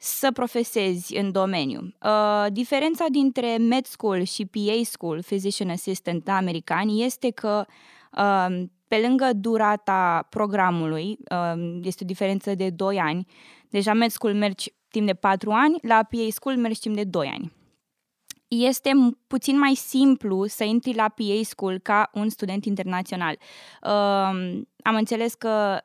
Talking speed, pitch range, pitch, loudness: 145 wpm, 190-235 Hz, 210 Hz, -24 LUFS